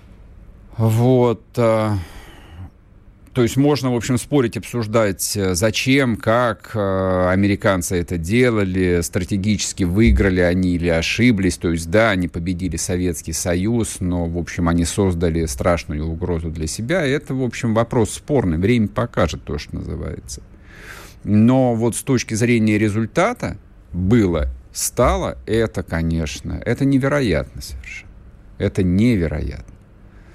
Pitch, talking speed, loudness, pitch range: 100 Hz, 115 wpm, -19 LUFS, 85-115 Hz